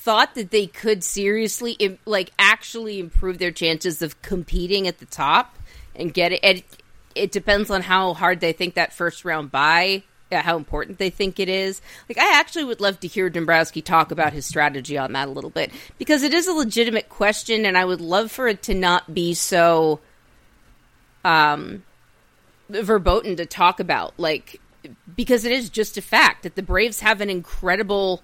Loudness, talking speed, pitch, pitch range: -20 LUFS, 185 wpm, 190 Hz, 170-215 Hz